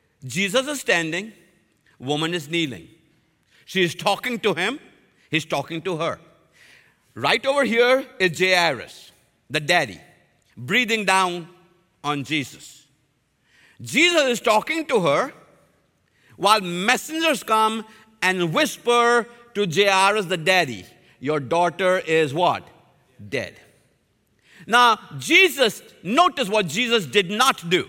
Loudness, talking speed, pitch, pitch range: -20 LUFS, 115 wpm, 185 Hz, 165-235 Hz